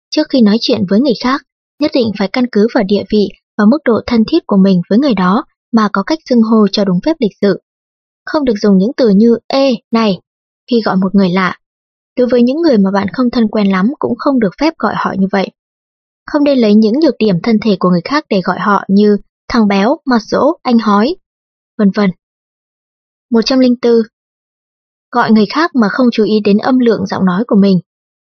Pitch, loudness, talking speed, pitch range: 220 Hz, -12 LUFS, 220 wpm, 200-255 Hz